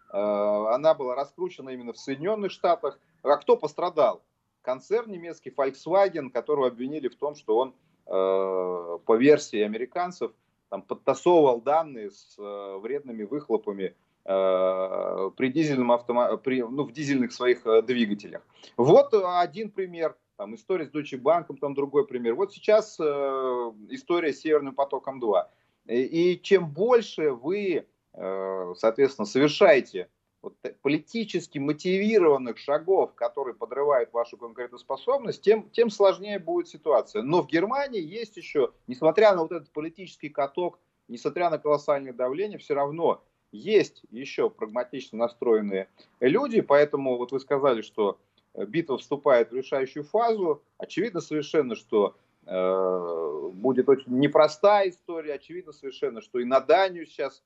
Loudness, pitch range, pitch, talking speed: -26 LUFS, 125-195 Hz, 150 Hz, 125 wpm